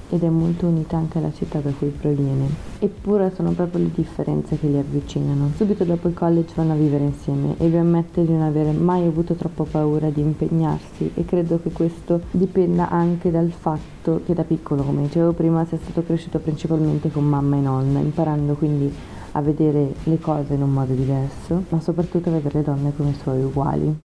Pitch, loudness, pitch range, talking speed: 160 Hz, -21 LUFS, 145-170 Hz, 195 wpm